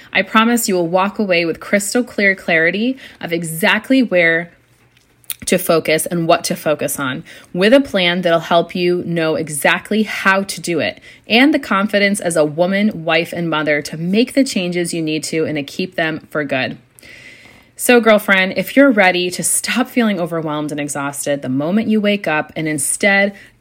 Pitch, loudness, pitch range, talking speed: 180 Hz, -15 LUFS, 160-205 Hz, 185 wpm